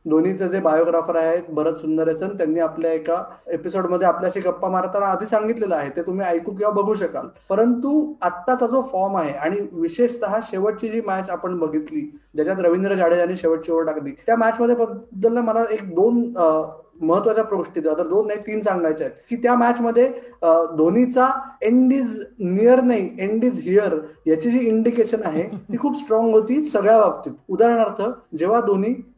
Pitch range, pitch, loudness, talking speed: 170-230 Hz, 205 Hz, -20 LUFS, 165 wpm